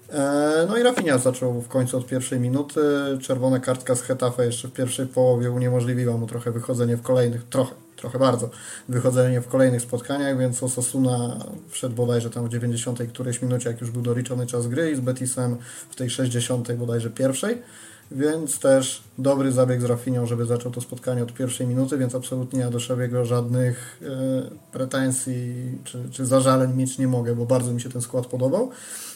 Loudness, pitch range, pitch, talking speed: -24 LUFS, 120-130 Hz, 125 Hz, 180 wpm